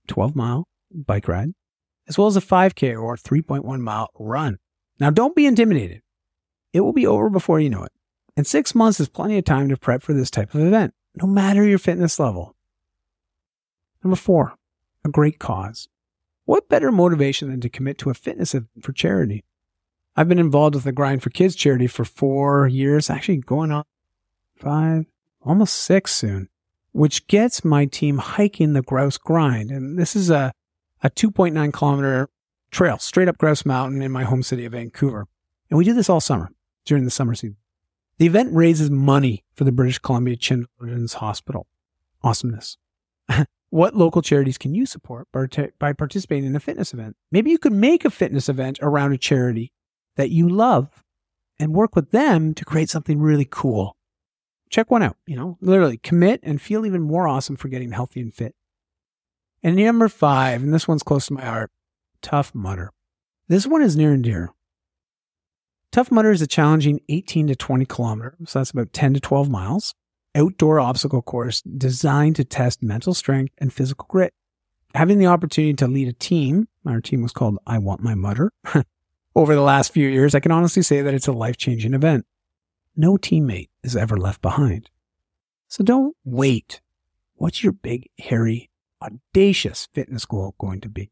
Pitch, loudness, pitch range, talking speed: 140 Hz, -19 LUFS, 115-165 Hz, 180 wpm